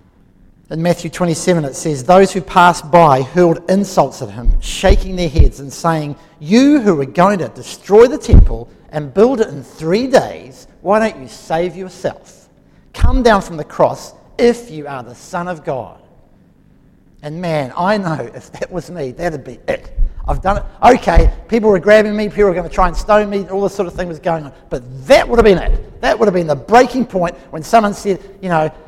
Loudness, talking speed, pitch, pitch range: -14 LUFS, 210 wpm, 175 Hz, 155-205 Hz